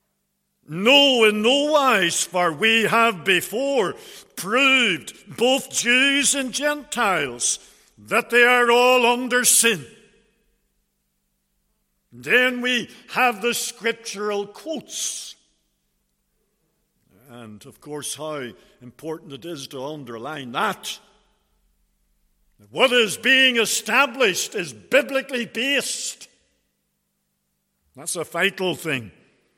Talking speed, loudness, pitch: 95 wpm, -19 LUFS, 220 Hz